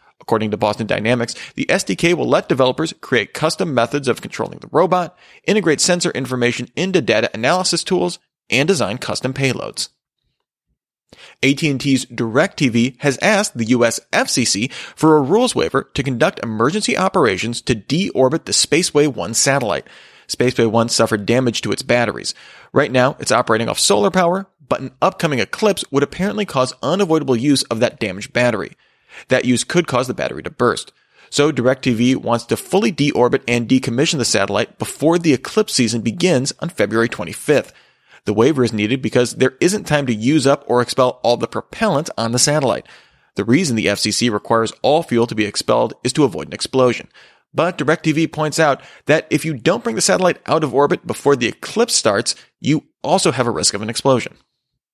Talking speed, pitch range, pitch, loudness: 175 wpm, 120-160 Hz, 130 Hz, -17 LUFS